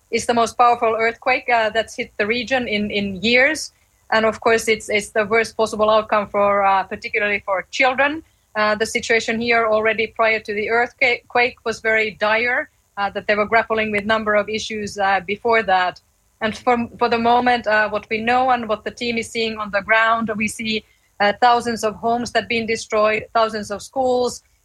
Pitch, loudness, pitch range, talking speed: 225 Hz, -19 LUFS, 215-235 Hz, 200 wpm